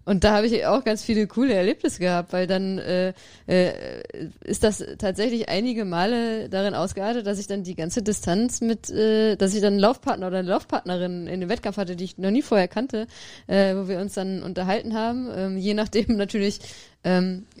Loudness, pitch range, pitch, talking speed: -24 LUFS, 185-225 Hz, 200 Hz, 200 wpm